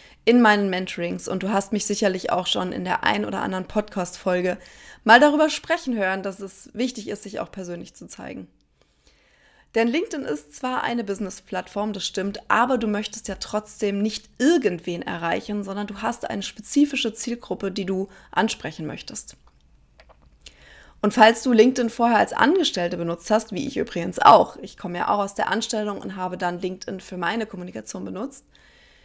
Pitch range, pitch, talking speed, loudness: 185-225 Hz, 205 Hz, 170 wpm, -22 LUFS